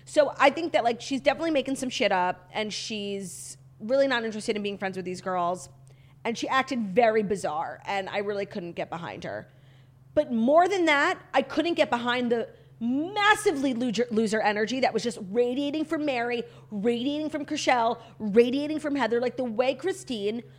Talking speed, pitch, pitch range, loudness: 185 wpm, 240 Hz, 205-280 Hz, -26 LUFS